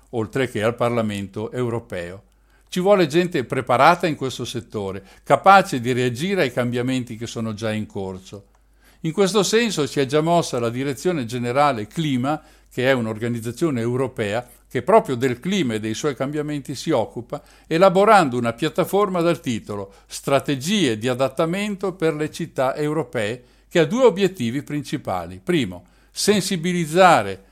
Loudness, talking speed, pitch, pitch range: -21 LUFS, 145 wpm, 135 Hz, 120-170 Hz